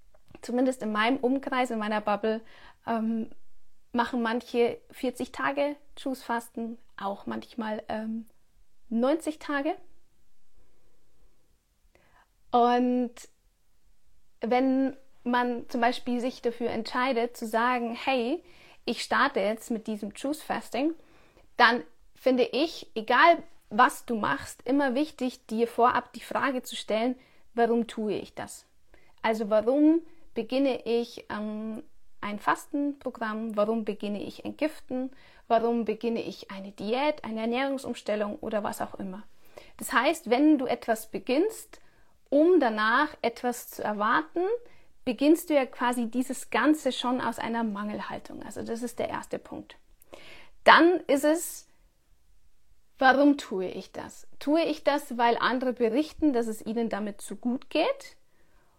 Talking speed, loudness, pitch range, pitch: 130 wpm, -28 LUFS, 225-280 Hz, 245 Hz